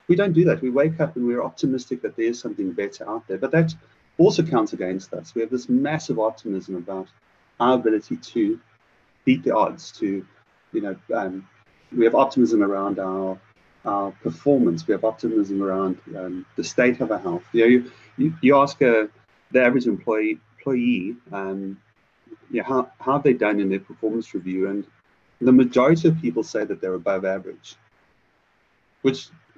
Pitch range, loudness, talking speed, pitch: 95-135 Hz, -22 LUFS, 185 wpm, 115 Hz